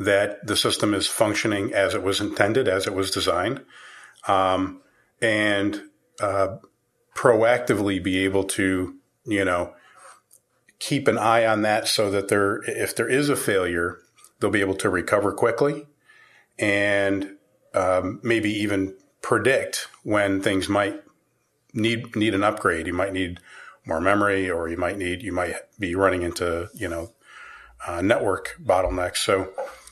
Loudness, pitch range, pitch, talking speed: -23 LUFS, 95-105 Hz, 100 Hz, 145 wpm